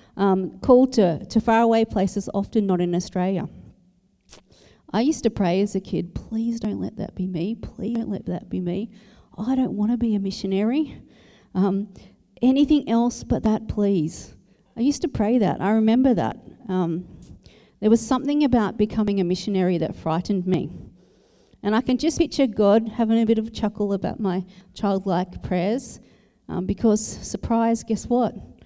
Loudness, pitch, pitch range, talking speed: -23 LUFS, 210 Hz, 190-230 Hz, 175 wpm